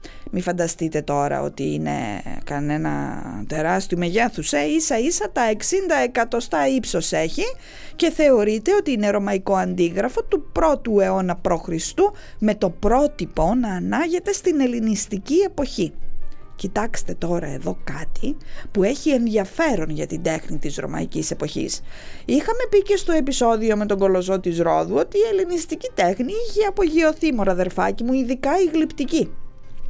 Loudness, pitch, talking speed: -21 LUFS, 220 Hz, 140 wpm